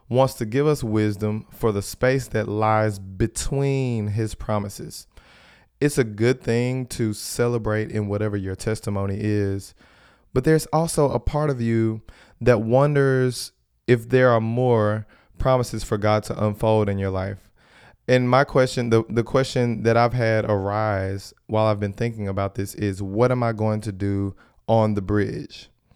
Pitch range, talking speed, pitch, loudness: 105-125 Hz, 165 wpm, 110 Hz, -22 LUFS